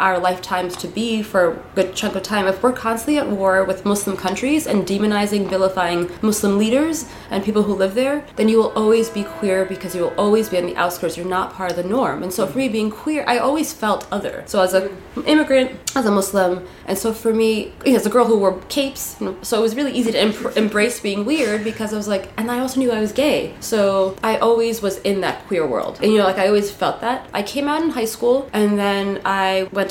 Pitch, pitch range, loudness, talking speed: 210 Hz, 190-235 Hz, -19 LUFS, 245 wpm